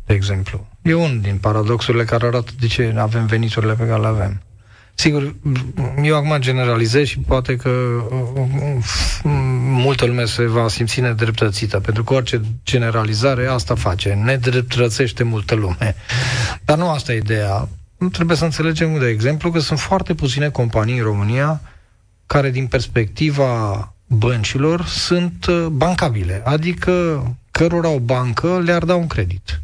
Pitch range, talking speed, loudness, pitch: 110-145 Hz, 145 wpm, -18 LUFS, 125 Hz